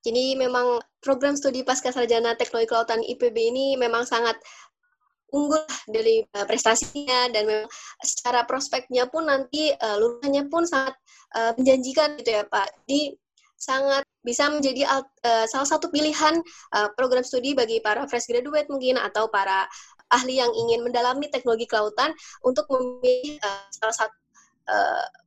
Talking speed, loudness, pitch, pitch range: 145 wpm, -24 LUFS, 255 Hz, 230-290 Hz